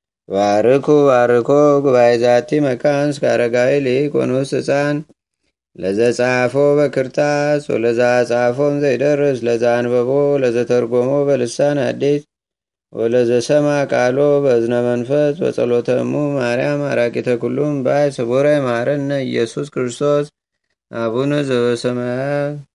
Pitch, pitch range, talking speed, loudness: 135 Hz, 120-145 Hz, 85 wpm, -16 LUFS